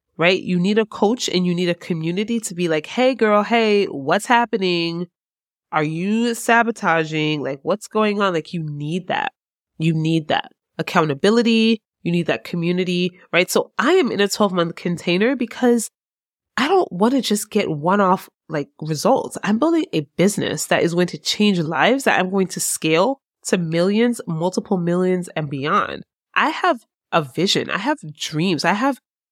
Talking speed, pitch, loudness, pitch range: 180 wpm, 185 Hz, -19 LUFS, 170-225 Hz